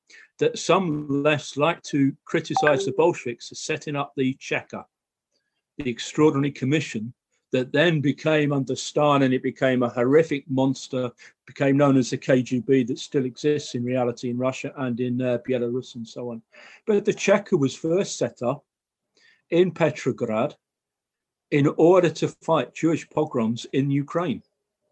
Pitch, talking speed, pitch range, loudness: 140 Hz, 150 wpm, 130-155 Hz, -23 LUFS